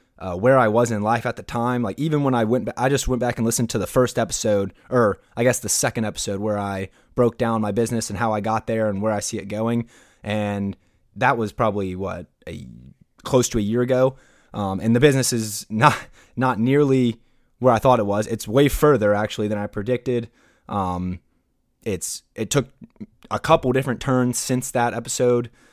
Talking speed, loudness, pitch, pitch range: 210 wpm, -21 LUFS, 115 Hz, 105-125 Hz